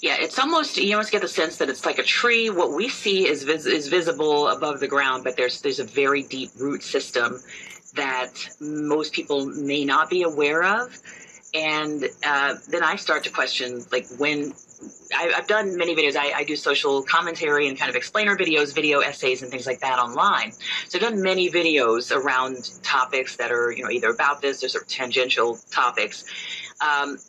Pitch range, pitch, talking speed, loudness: 130-170 Hz, 145 Hz, 200 wpm, -22 LUFS